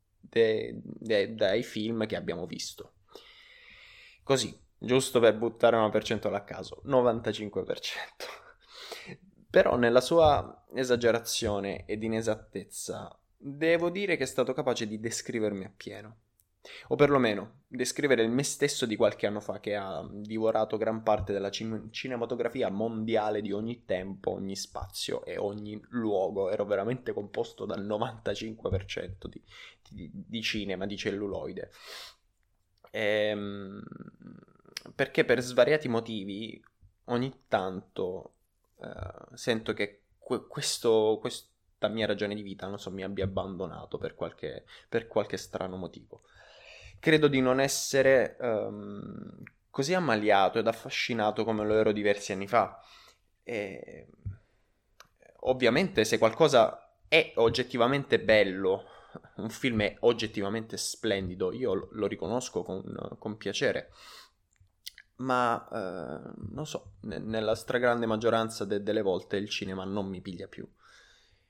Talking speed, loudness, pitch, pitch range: 125 wpm, -29 LUFS, 110 Hz, 100-120 Hz